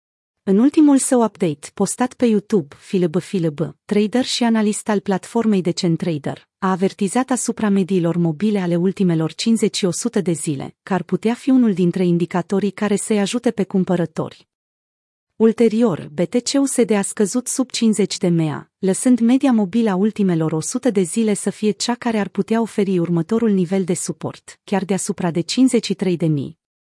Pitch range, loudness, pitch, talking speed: 180-230 Hz, -19 LUFS, 200 Hz, 155 wpm